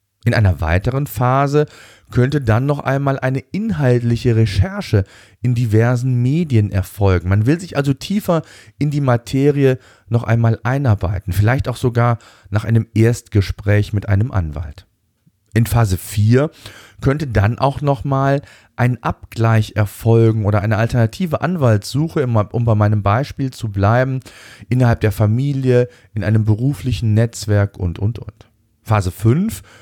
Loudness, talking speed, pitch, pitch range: -17 LUFS, 135 wpm, 115 Hz, 105-130 Hz